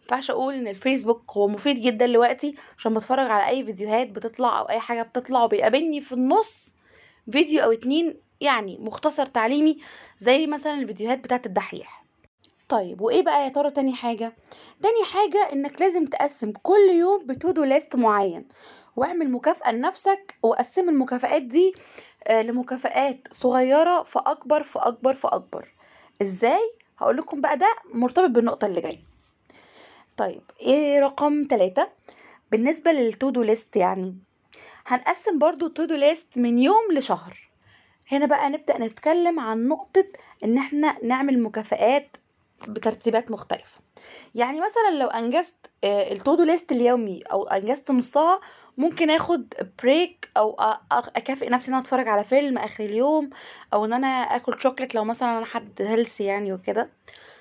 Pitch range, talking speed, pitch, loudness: 230-310 Hz, 135 wpm, 265 Hz, -23 LUFS